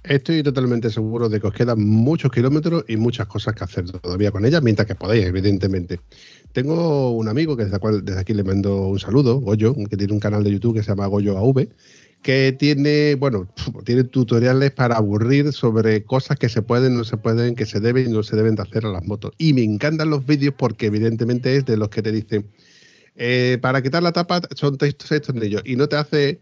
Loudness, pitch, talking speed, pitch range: -19 LUFS, 120 Hz, 225 wpm, 105-140 Hz